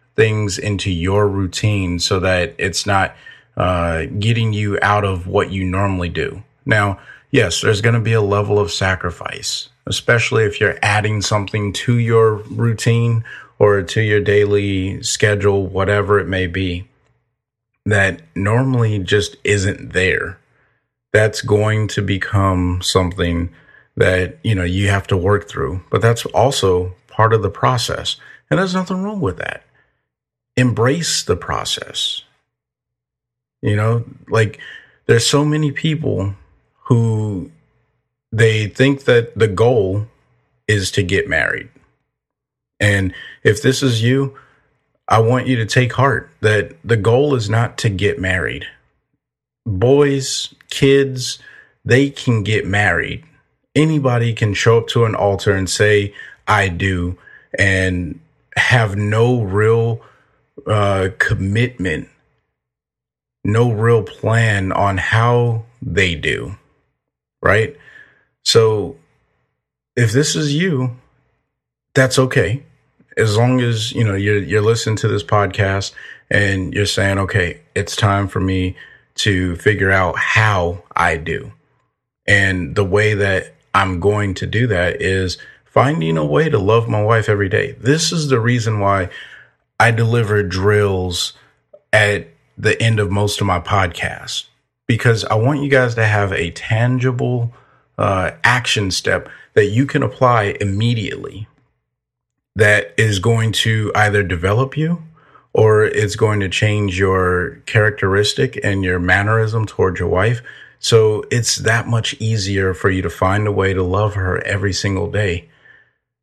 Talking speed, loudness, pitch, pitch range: 135 wpm, -16 LUFS, 105 Hz, 95-120 Hz